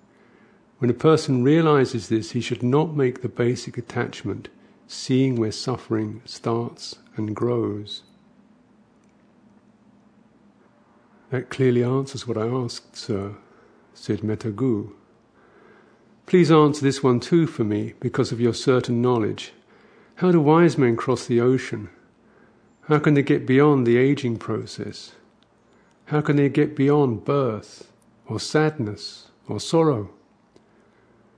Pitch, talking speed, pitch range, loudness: 130 Hz, 120 wpm, 115-150 Hz, -22 LUFS